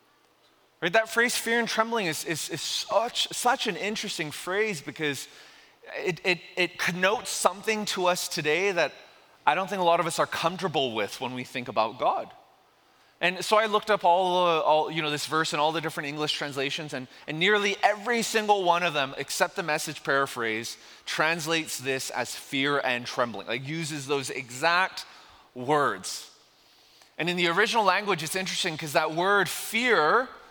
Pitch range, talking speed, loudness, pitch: 150-200 Hz, 180 wpm, -26 LUFS, 170 Hz